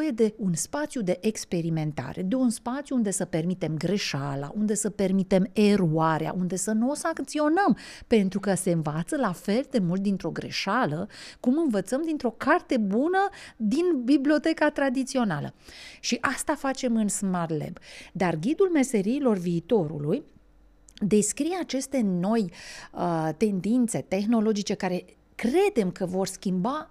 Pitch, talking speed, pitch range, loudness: 215 Hz, 135 wpm, 185-265 Hz, -26 LUFS